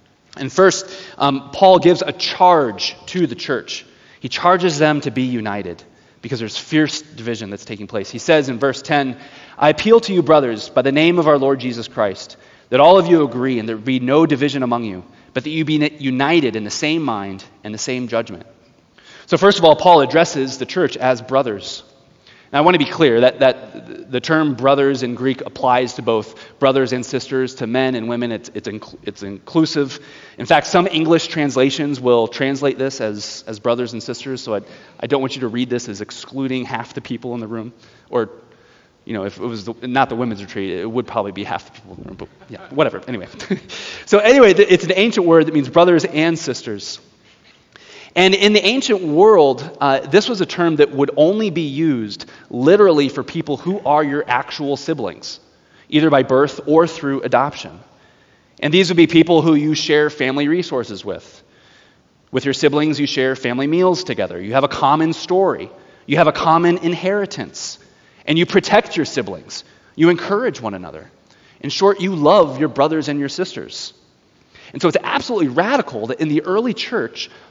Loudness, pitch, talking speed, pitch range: -16 LUFS, 140 Hz, 200 wpm, 125-165 Hz